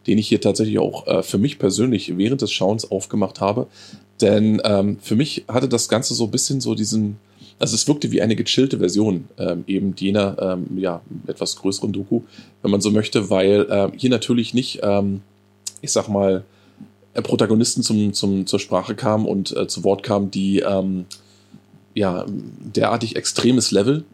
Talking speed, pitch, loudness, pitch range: 175 wpm, 100 Hz, -20 LUFS, 95-110 Hz